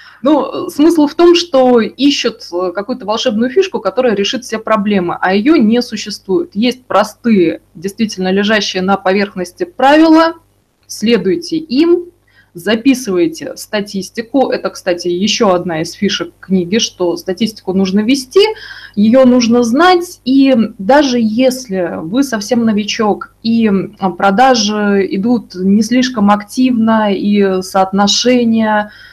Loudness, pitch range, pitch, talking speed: -12 LUFS, 195-260 Hz, 220 Hz, 115 wpm